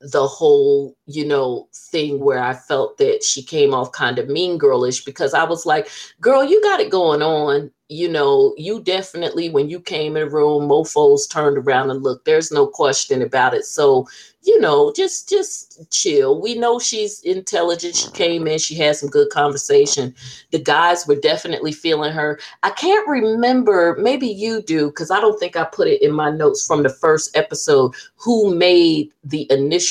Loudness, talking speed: -17 LUFS, 190 wpm